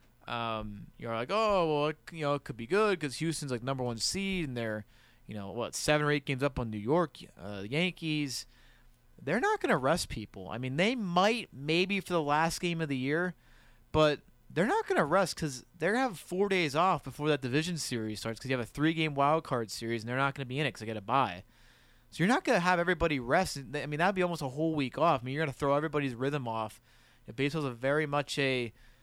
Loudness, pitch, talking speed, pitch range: -31 LUFS, 145 Hz, 265 wpm, 125-170 Hz